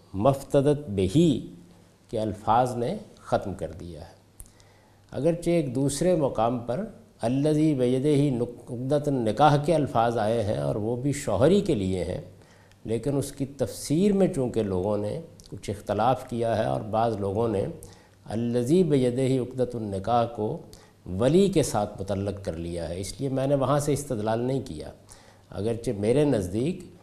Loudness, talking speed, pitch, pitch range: -26 LUFS, 155 wpm, 120 Hz, 100-140 Hz